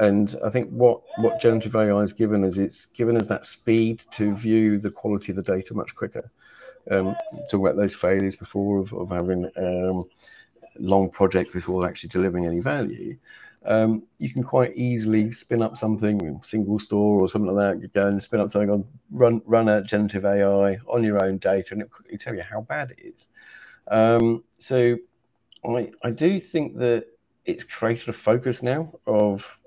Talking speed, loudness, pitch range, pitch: 190 wpm, -23 LUFS, 100-115 Hz, 105 Hz